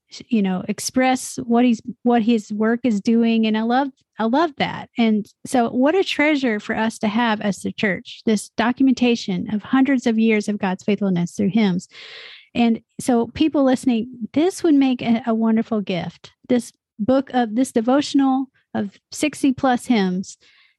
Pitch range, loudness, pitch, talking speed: 215-260 Hz, -20 LUFS, 235 Hz, 170 wpm